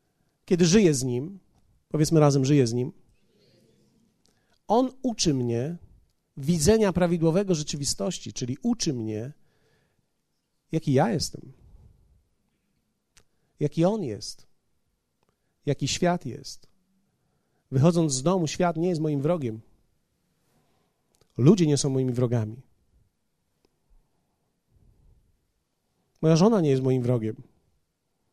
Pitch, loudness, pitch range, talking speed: 150 Hz, -25 LUFS, 125-175 Hz, 95 wpm